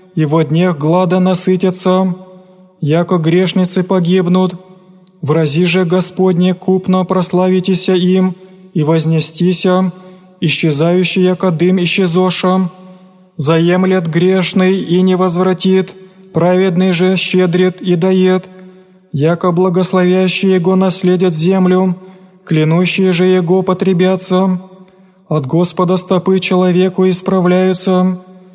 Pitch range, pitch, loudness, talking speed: 180-185 Hz, 185 Hz, -12 LUFS, 90 wpm